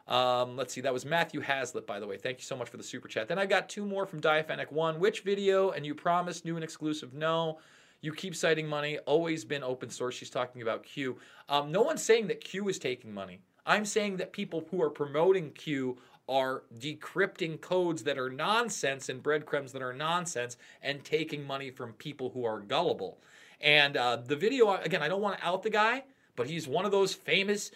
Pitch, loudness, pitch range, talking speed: 155 Hz, -31 LUFS, 135-190 Hz, 220 wpm